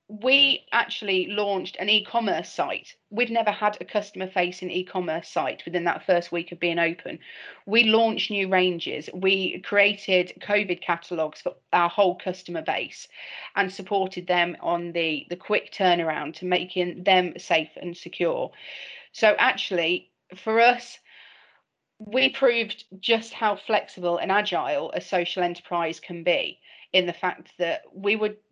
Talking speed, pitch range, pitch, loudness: 145 wpm, 175-210 Hz, 185 Hz, -24 LUFS